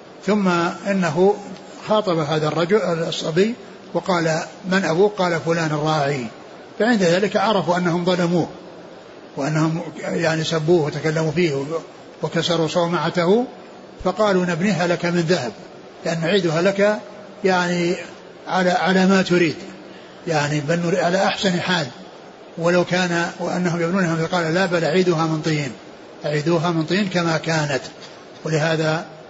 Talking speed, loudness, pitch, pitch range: 120 wpm, -20 LUFS, 175 Hz, 160-190 Hz